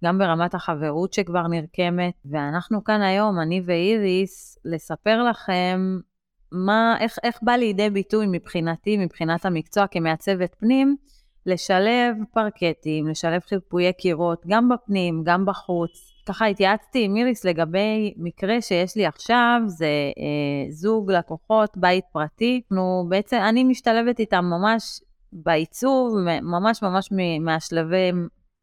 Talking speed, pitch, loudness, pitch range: 120 wpm, 185 Hz, -22 LUFS, 170-215 Hz